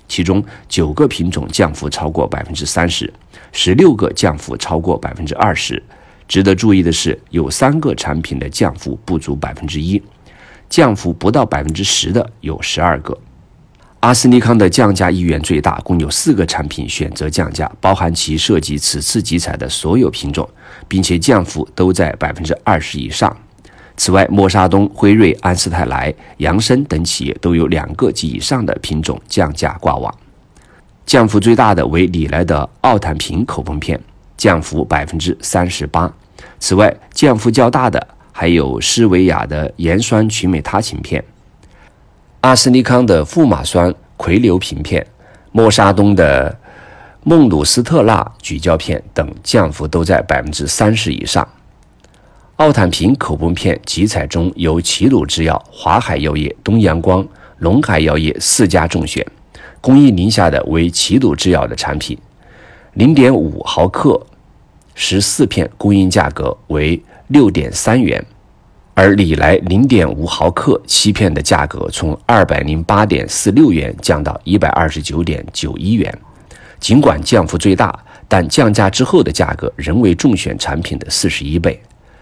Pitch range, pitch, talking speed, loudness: 80-100 Hz, 90 Hz, 225 characters per minute, -13 LUFS